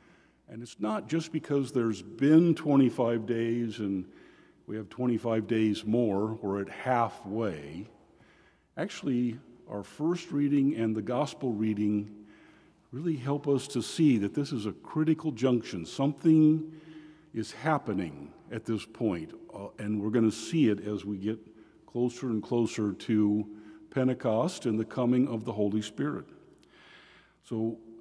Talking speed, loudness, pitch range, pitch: 140 wpm, -30 LUFS, 110-140 Hz, 115 Hz